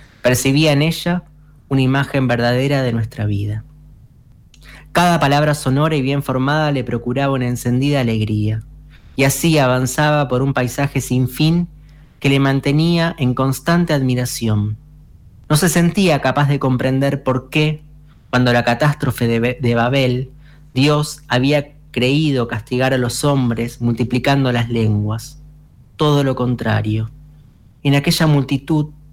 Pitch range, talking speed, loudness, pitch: 125-150 Hz, 135 wpm, -17 LUFS, 135 Hz